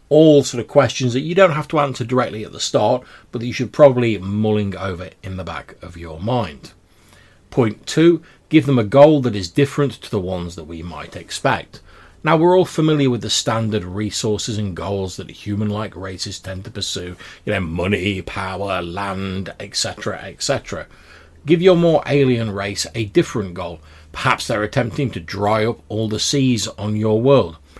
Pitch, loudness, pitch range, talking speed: 105 Hz, -18 LUFS, 95-130 Hz, 185 wpm